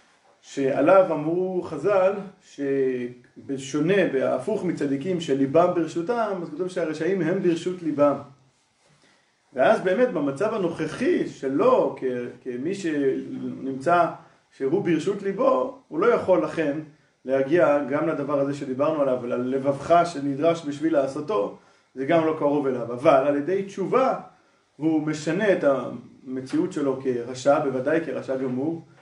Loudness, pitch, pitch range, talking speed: -24 LUFS, 155 Hz, 135-180 Hz, 120 wpm